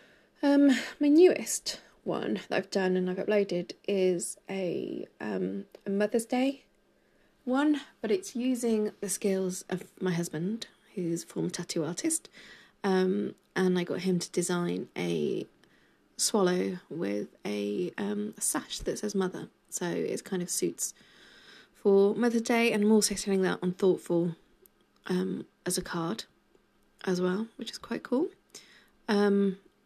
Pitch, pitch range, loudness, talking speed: 190 Hz, 180-220 Hz, -30 LUFS, 145 wpm